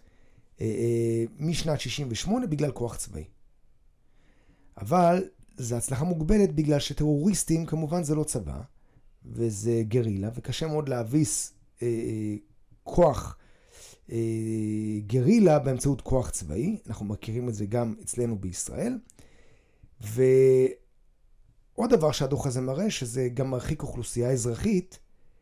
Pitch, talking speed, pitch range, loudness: 130 Hz, 105 wpm, 115-155 Hz, -27 LUFS